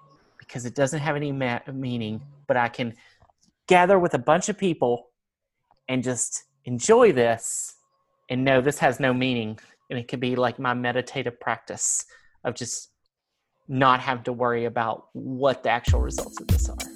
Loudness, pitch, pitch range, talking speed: -24 LUFS, 125 Hz, 120-135 Hz, 170 wpm